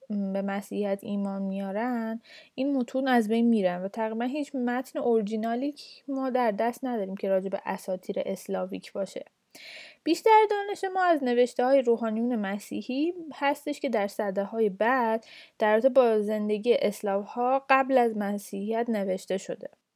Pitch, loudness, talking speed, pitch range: 230 Hz, -27 LUFS, 140 wpm, 205-270 Hz